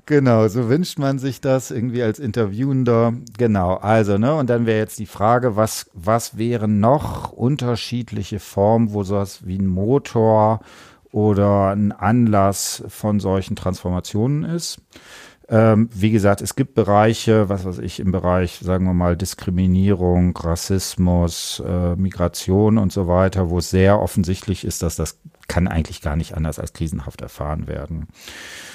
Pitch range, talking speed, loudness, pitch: 90-115 Hz, 150 wpm, -19 LUFS, 105 Hz